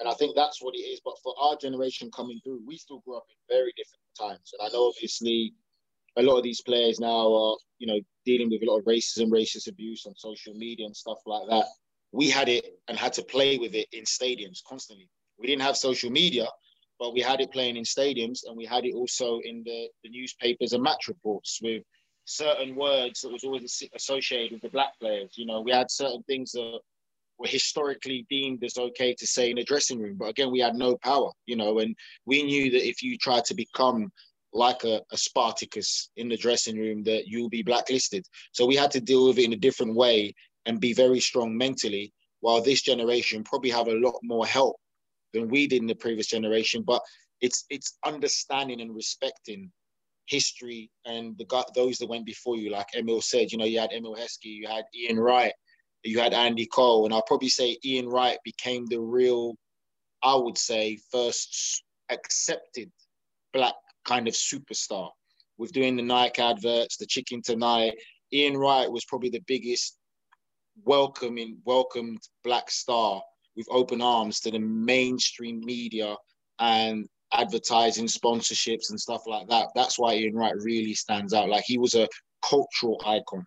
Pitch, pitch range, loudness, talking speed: 120 Hz, 115-130 Hz, -26 LUFS, 195 wpm